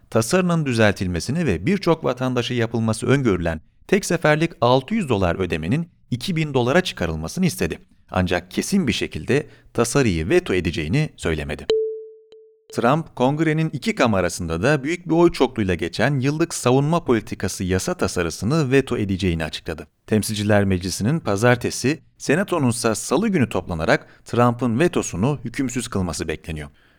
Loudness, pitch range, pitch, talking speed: -21 LUFS, 95-160 Hz, 125 Hz, 120 wpm